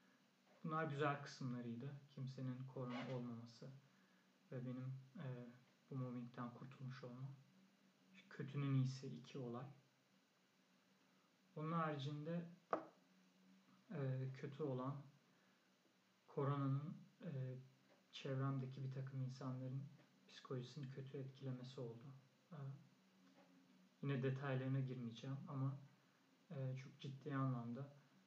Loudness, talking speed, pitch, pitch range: -49 LUFS, 85 wpm, 135 Hz, 125-145 Hz